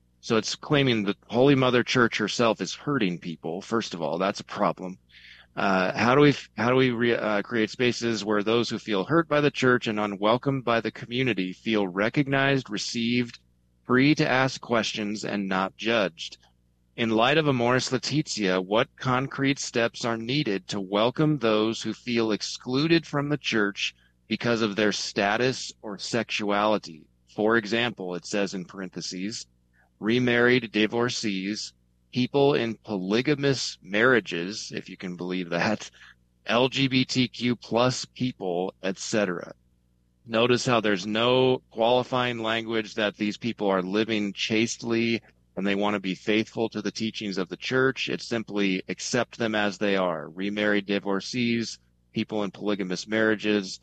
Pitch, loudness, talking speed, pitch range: 110 Hz, -25 LUFS, 150 wpm, 100-125 Hz